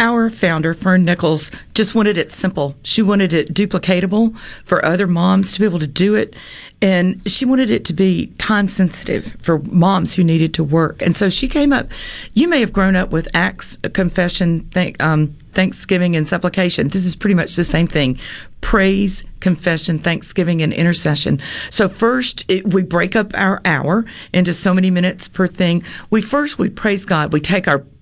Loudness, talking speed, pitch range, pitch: -16 LUFS, 185 wpm, 170-200 Hz, 185 Hz